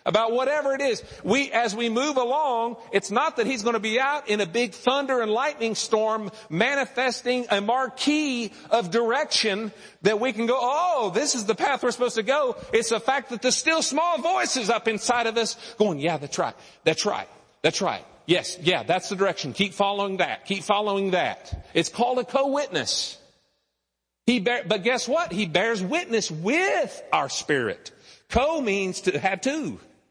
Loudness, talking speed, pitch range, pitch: -24 LUFS, 185 wpm, 210-265 Hz, 235 Hz